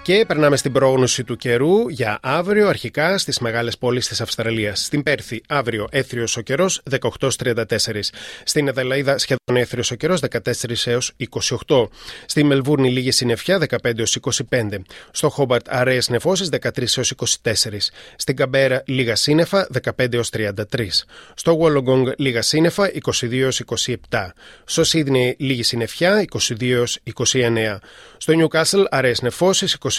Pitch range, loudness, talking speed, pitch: 120-145 Hz, -19 LUFS, 135 wpm, 130 Hz